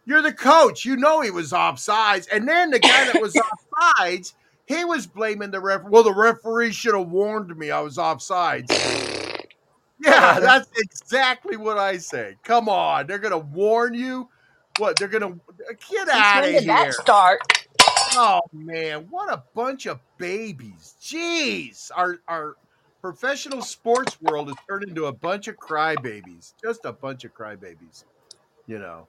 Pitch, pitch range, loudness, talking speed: 205 Hz, 170-255 Hz, -19 LUFS, 165 wpm